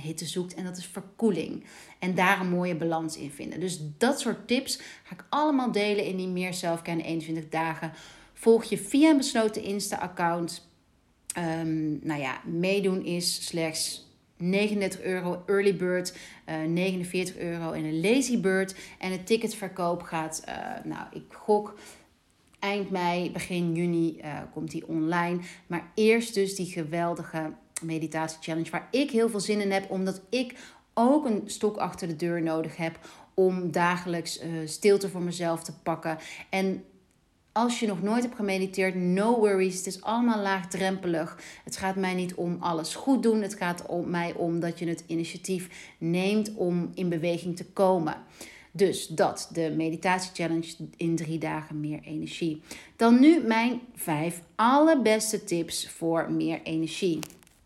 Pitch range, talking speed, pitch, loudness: 165-200 Hz, 160 wpm, 180 Hz, -28 LUFS